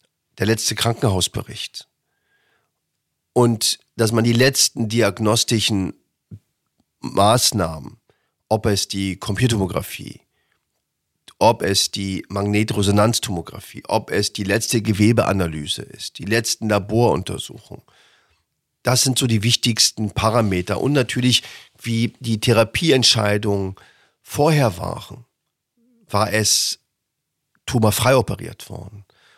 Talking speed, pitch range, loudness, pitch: 90 wpm, 100-120 Hz, -19 LUFS, 110 Hz